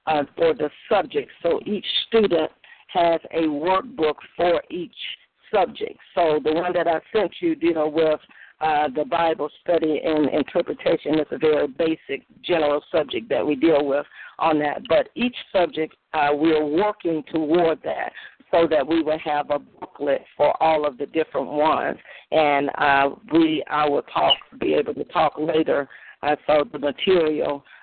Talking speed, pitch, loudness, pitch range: 170 wpm, 160 Hz, -22 LUFS, 150-180 Hz